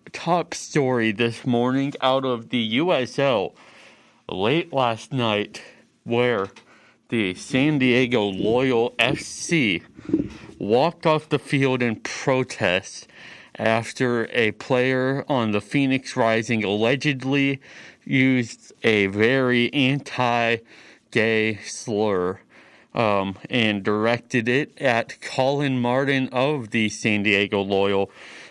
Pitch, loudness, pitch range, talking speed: 120 Hz, -22 LUFS, 110-135 Hz, 105 wpm